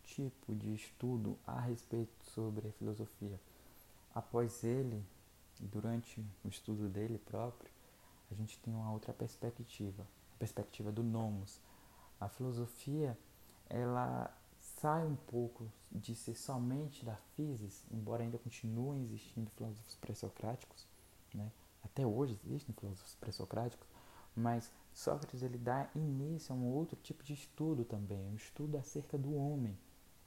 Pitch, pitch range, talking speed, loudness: 115 Hz, 105-125 Hz, 130 wpm, -43 LUFS